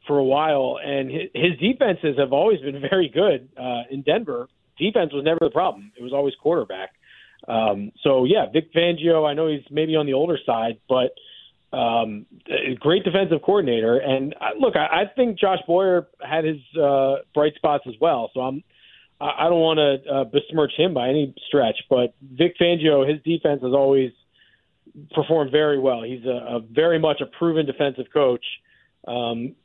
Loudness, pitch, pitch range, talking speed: -21 LUFS, 145 Hz, 130-160 Hz, 180 wpm